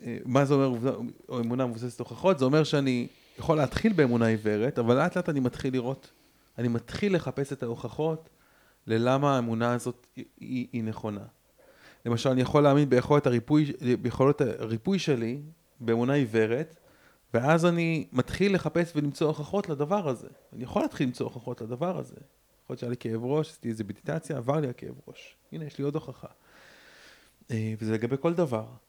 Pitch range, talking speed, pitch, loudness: 120-150 Hz, 165 wpm, 135 Hz, -28 LUFS